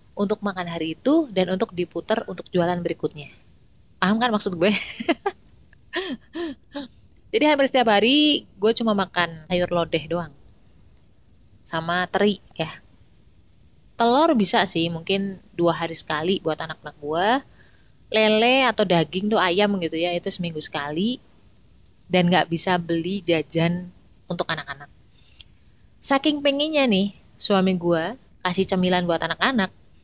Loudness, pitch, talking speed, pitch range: -22 LUFS, 185 Hz, 125 wpm, 165-220 Hz